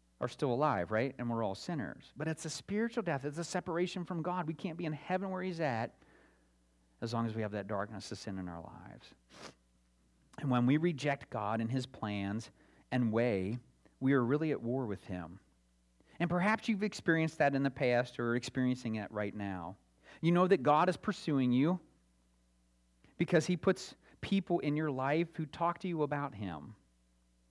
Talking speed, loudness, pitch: 195 wpm, -35 LUFS, 125 Hz